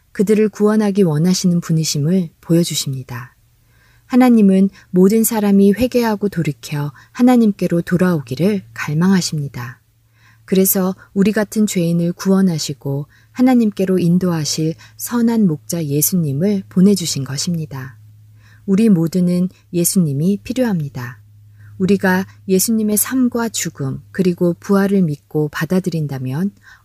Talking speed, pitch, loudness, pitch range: 295 characters per minute, 175 Hz, -16 LUFS, 145-200 Hz